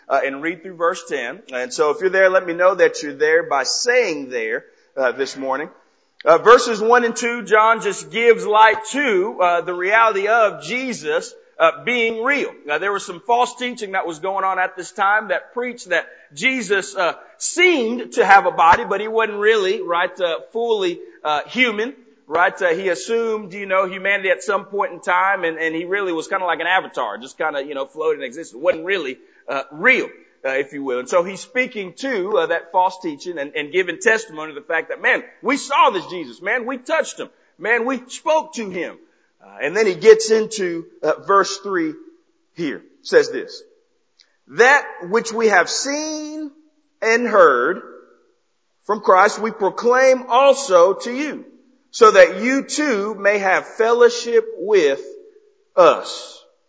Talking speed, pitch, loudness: 190 wpm, 235 Hz, -18 LUFS